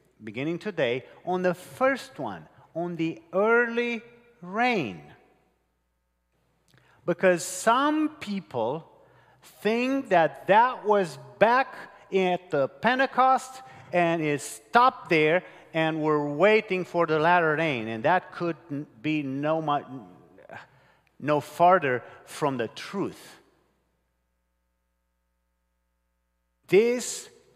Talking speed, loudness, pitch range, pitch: 95 wpm, -25 LUFS, 135-215 Hz, 170 Hz